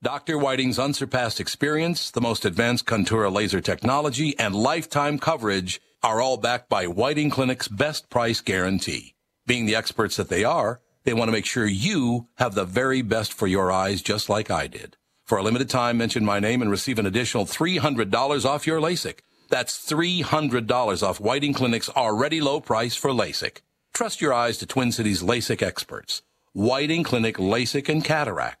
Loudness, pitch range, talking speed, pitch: -23 LUFS, 110-145 Hz, 175 wpm, 125 Hz